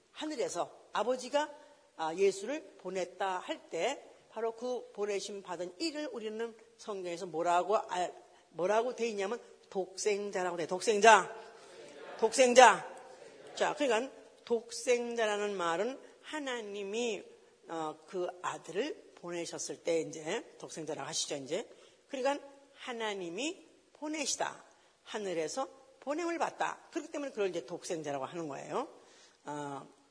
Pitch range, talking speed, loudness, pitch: 185-290 Hz, 265 characters per minute, -34 LUFS, 225 Hz